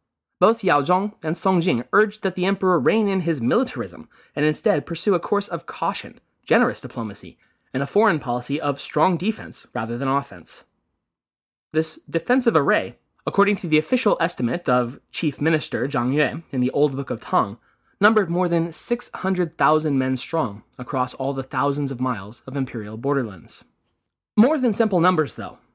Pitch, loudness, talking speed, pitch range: 155 Hz, -22 LUFS, 170 wpm, 130-190 Hz